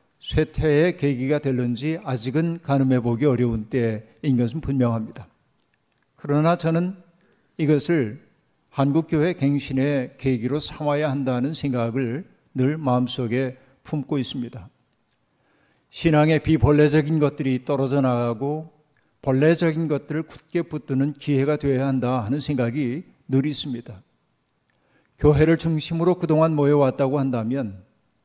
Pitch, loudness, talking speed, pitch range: 140 Hz, -22 LUFS, 280 characters per minute, 130-155 Hz